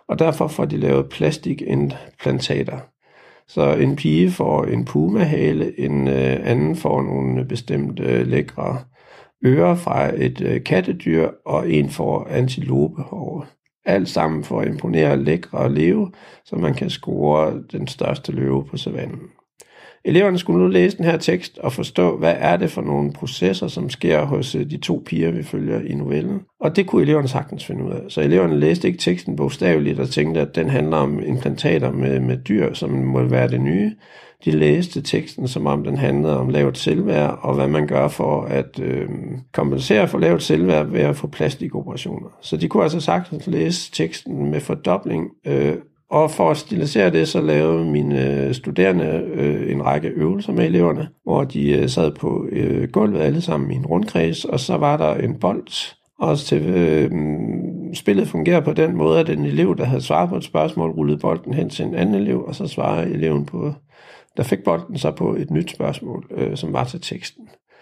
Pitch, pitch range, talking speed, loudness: 75 Hz, 70-90 Hz, 180 wpm, -20 LUFS